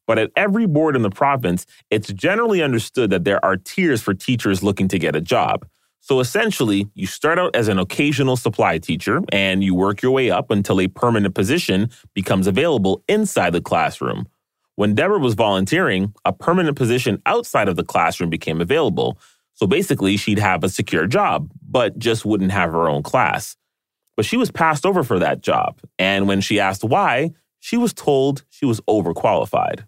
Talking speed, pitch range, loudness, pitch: 185 wpm, 100-150 Hz, -19 LUFS, 110 Hz